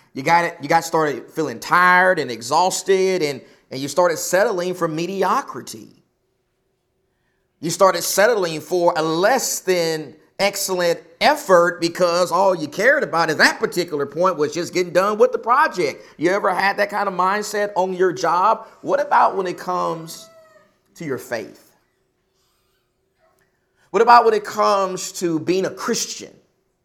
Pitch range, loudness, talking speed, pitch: 170-195 Hz, -18 LUFS, 155 wpm, 180 Hz